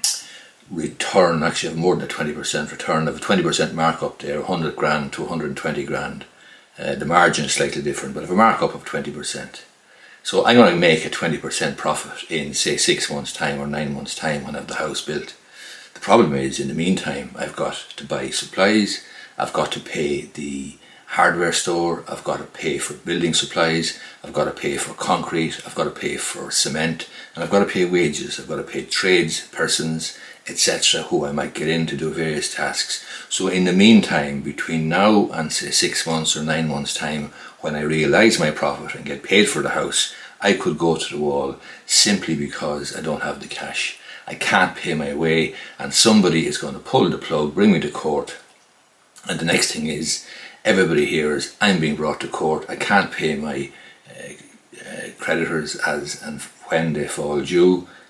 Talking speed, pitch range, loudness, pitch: 205 wpm, 75-85 Hz, -20 LUFS, 80 Hz